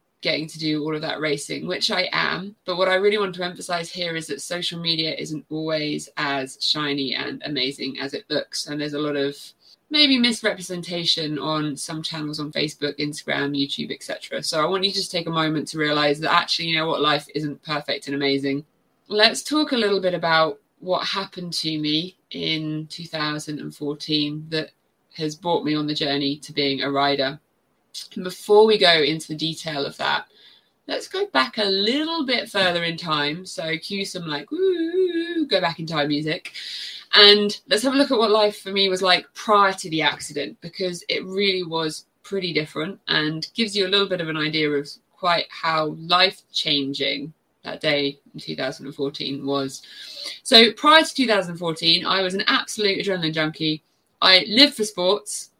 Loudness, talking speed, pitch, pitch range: -21 LUFS, 185 wpm, 160 Hz, 150-195 Hz